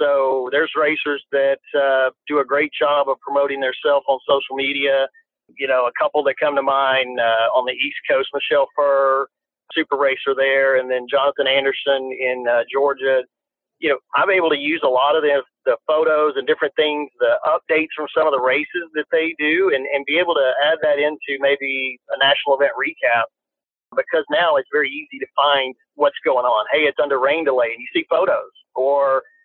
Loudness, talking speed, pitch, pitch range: -18 LUFS, 200 wpm, 140 Hz, 135-155 Hz